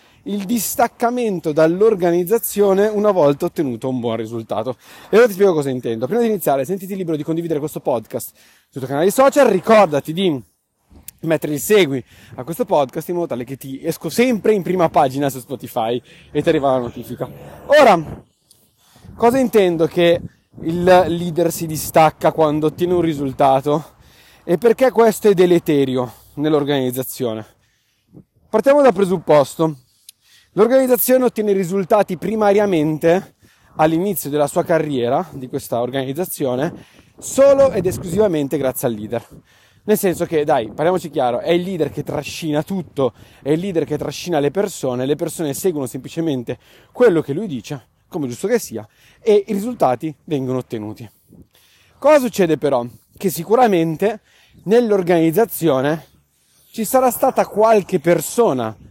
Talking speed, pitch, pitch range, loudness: 140 wpm, 165 Hz, 135-200 Hz, -17 LUFS